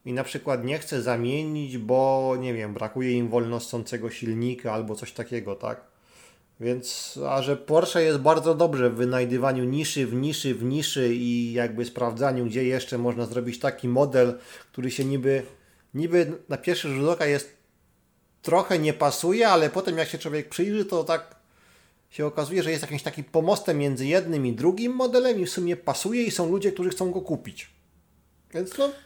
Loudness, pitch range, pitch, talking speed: -25 LUFS, 120-165 Hz, 140 Hz, 180 wpm